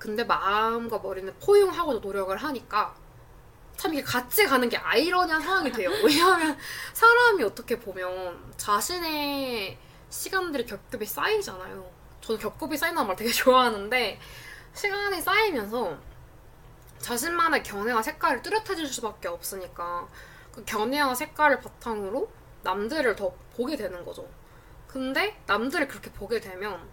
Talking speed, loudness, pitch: 315 characters per minute, -26 LUFS, 255 Hz